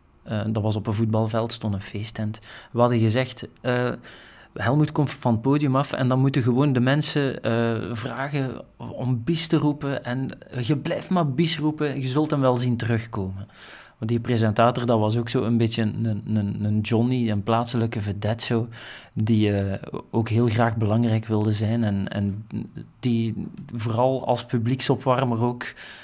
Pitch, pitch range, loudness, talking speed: 120 Hz, 110-130 Hz, -24 LUFS, 175 wpm